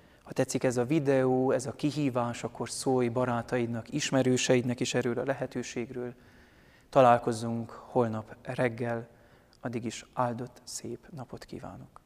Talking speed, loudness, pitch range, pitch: 125 wpm, -30 LUFS, 120-130 Hz, 125 Hz